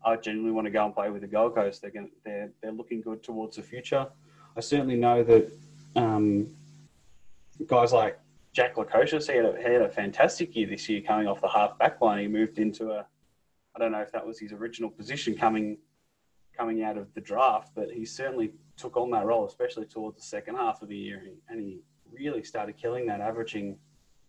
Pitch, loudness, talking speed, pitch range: 110 Hz, -28 LUFS, 205 wpm, 105-135 Hz